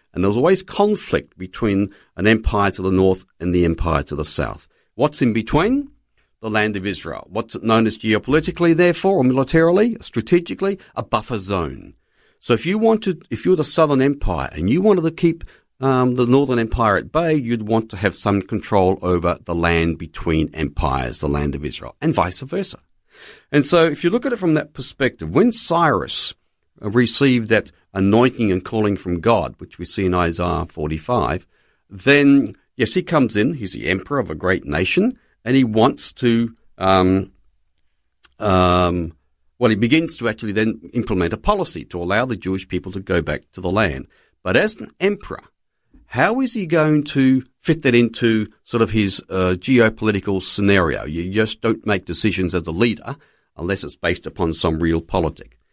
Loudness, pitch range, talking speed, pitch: -19 LUFS, 90-135 Hz, 180 wpm, 110 Hz